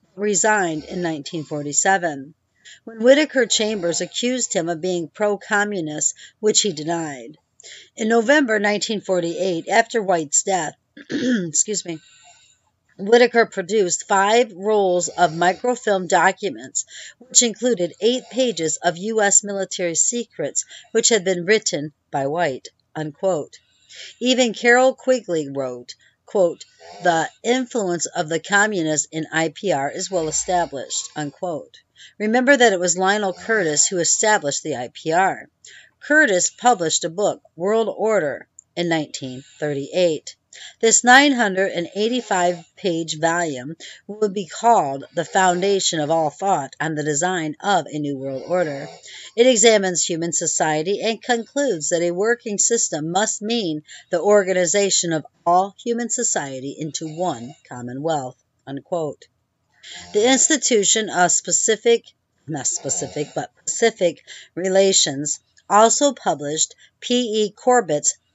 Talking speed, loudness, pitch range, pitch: 125 wpm, -19 LUFS, 160-220 Hz, 185 Hz